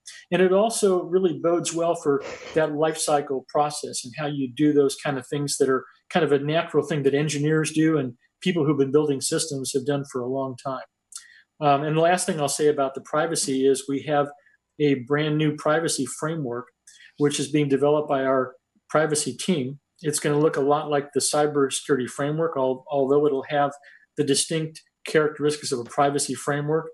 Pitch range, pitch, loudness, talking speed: 140-155 Hz, 145 Hz, -23 LUFS, 200 wpm